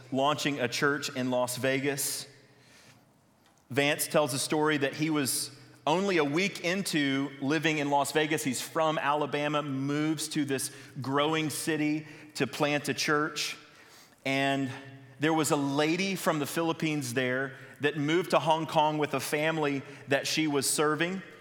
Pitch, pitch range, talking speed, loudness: 145 Hz, 140-155 Hz, 150 wpm, -29 LUFS